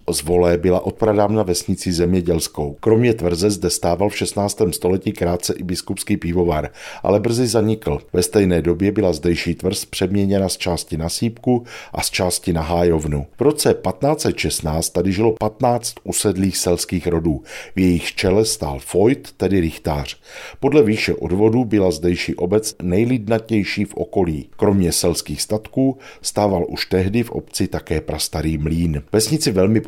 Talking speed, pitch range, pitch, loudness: 150 wpm, 85-105 Hz, 95 Hz, -19 LUFS